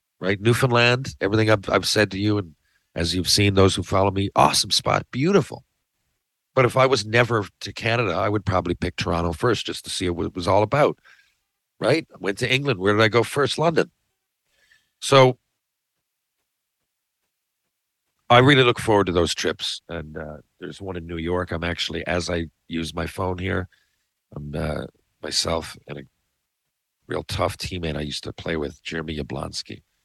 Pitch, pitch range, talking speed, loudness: 95 Hz, 85-110 Hz, 180 wpm, -21 LUFS